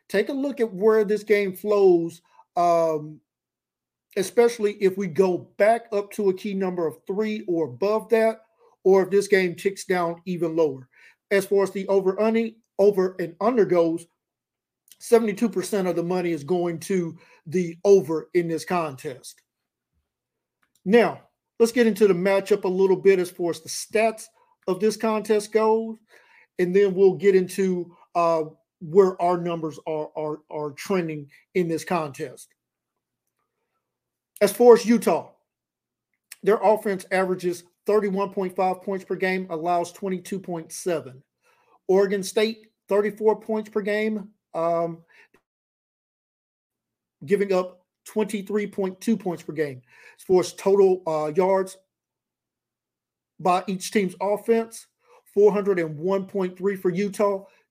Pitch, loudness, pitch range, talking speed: 195 Hz, -23 LUFS, 175-210 Hz, 150 wpm